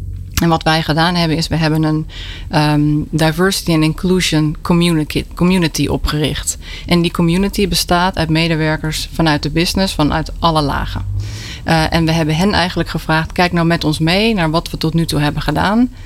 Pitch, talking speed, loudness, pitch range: 160 Hz, 175 wpm, -15 LUFS, 150-170 Hz